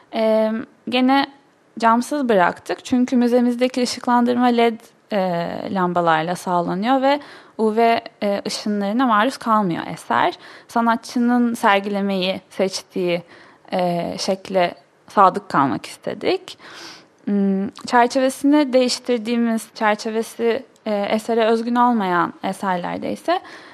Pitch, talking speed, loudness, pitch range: 230 Hz, 75 wpm, -20 LUFS, 195-250 Hz